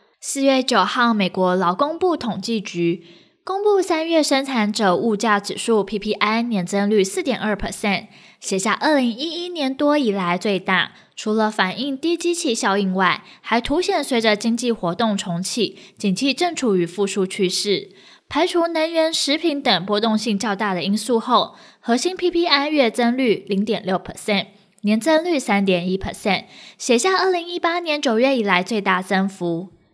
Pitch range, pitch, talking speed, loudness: 195-280 Hz, 220 Hz, 285 characters per minute, -20 LUFS